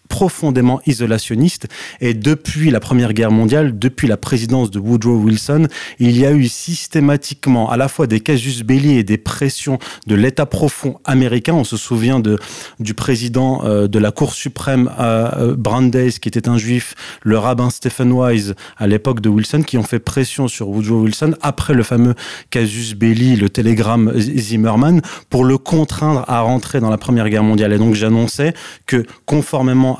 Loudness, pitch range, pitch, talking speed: -15 LUFS, 110-135 Hz, 125 Hz, 170 wpm